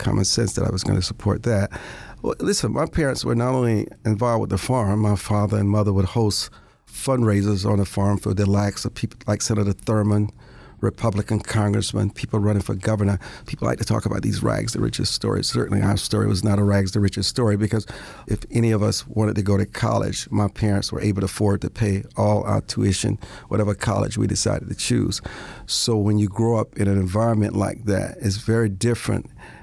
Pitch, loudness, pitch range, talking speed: 105 Hz, -22 LUFS, 100-115 Hz, 215 wpm